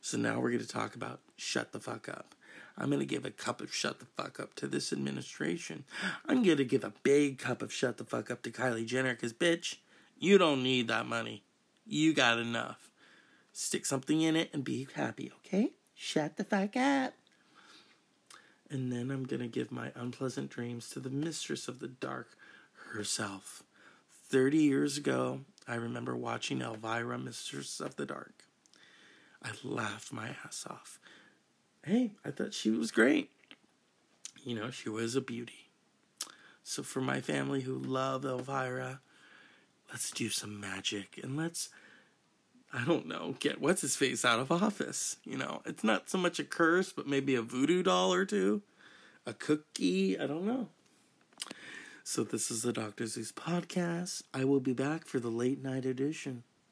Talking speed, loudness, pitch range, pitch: 170 wpm, -34 LUFS, 115-155 Hz, 130 Hz